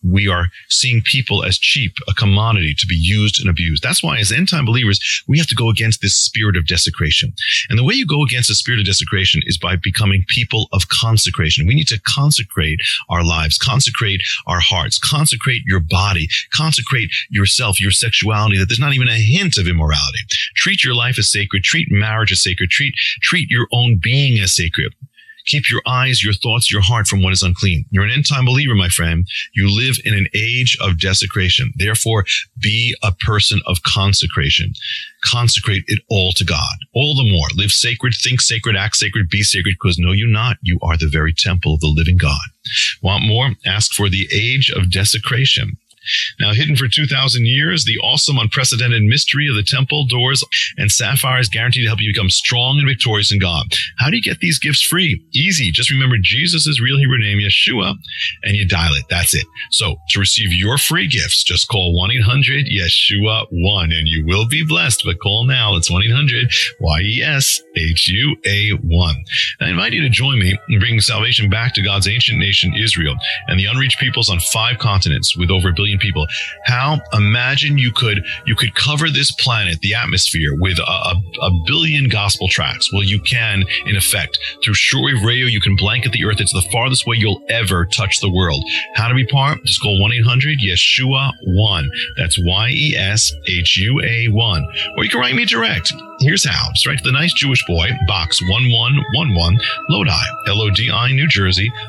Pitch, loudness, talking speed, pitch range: 110 Hz, -14 LUFS, 200 wpm, 95-125 Hz